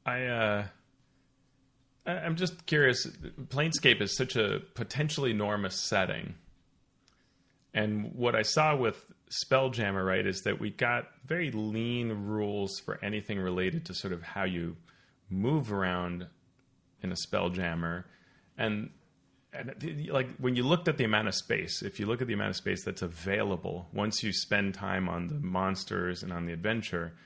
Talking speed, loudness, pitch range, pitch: 155 wpm, -31 LUFS, 95-130 Hz, 105 Hz